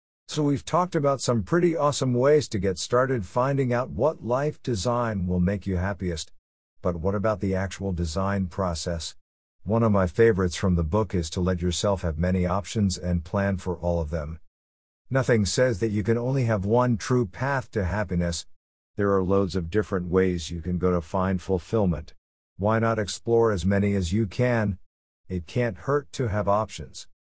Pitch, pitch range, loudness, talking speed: 100 Hz, 90-115 Hz, -25 LUFS, 185 wpm